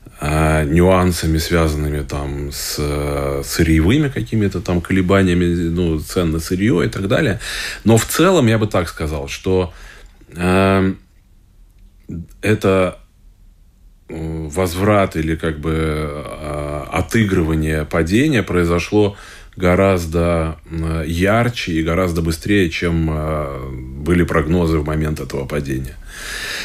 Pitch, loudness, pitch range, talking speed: 85 Hz, -17 LUFS, 75-95 Hz, 100 wpm